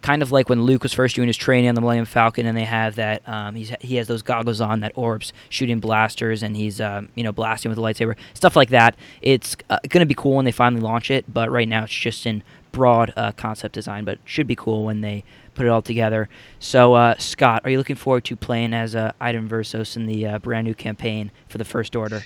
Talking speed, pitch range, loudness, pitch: 255 wpm, 110-125 Hz, -20 LUFS, 115 Hz